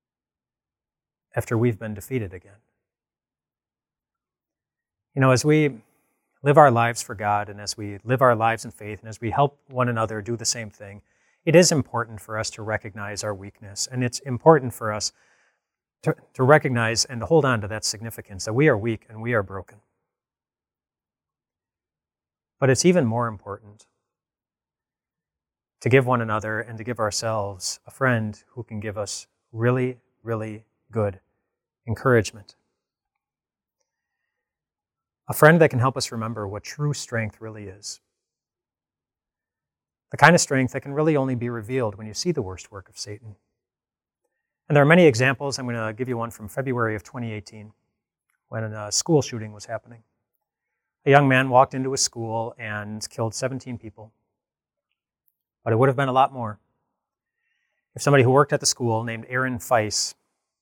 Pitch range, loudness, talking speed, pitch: 105-130 Hz, -22 LUFS, 165 wpm, 115 Hz